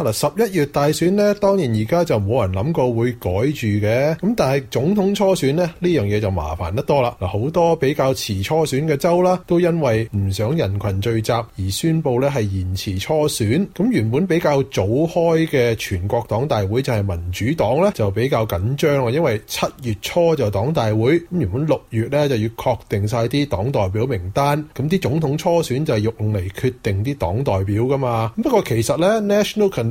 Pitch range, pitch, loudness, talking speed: 105-160 Hz, 130 Hz, -19 LUFS, 305 characters per minute